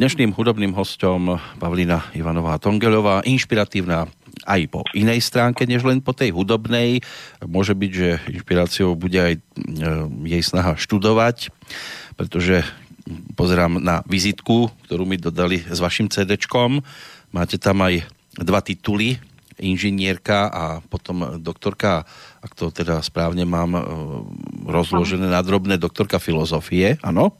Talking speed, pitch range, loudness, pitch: 120 wpm, 85-110 Hz, -20 LUFS, 95 Hz